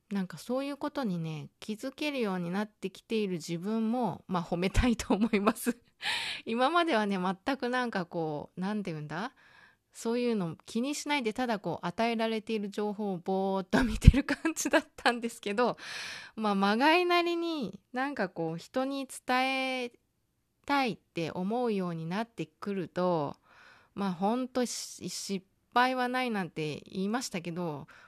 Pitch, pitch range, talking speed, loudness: 220 Hz, 190-255 Hz, 325 characters per minute, -31 LUFS